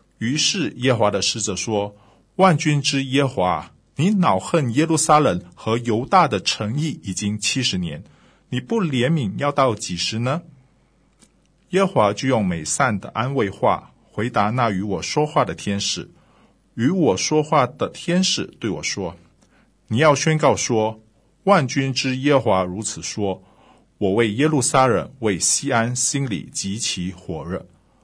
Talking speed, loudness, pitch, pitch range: 220 characters per minute, -20 LUFS, 125 Hz, 105-150 Hz